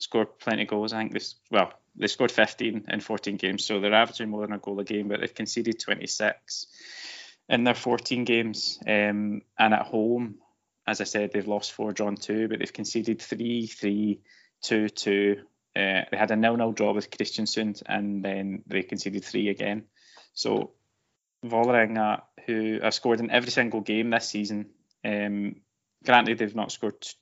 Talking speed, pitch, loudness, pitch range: 180 wpm, 110 Hz, -27 LUFS, 105-115 Hz